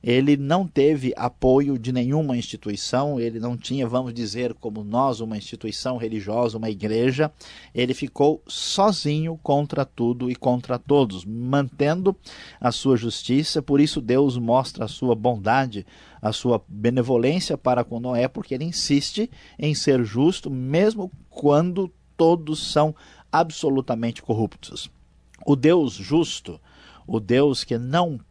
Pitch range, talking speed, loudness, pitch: 120-145 Hz, 135 wpm, -23 LUFS, 130 Hz